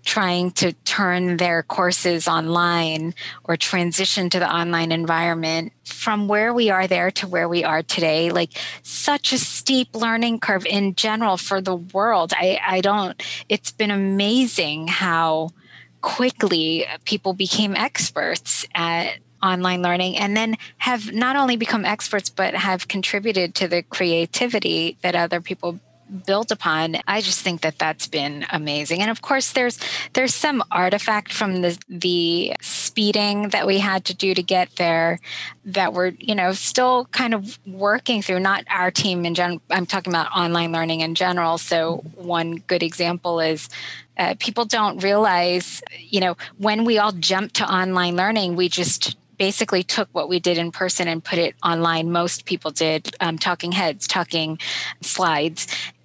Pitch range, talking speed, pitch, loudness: 170-210 Hz, 160 wpm, 185 Hz, -20 LUFS